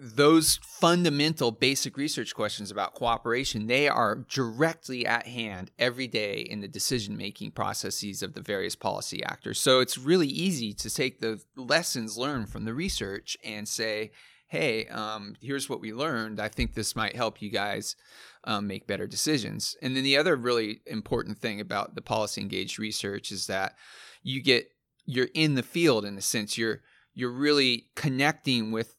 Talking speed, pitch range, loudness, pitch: 170 wpm, 110-135 Hz, -28 LUFS, 120 Hz